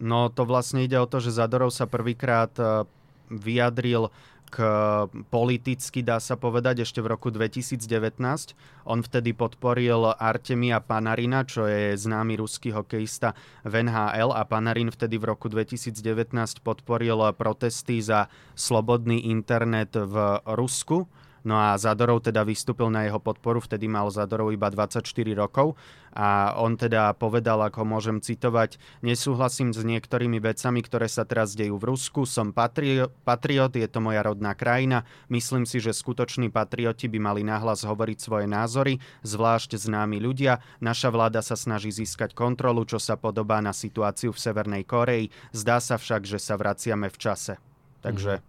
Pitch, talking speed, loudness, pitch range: 115 Hz, 150 wpm, -26 LUFS, 110-125 Hz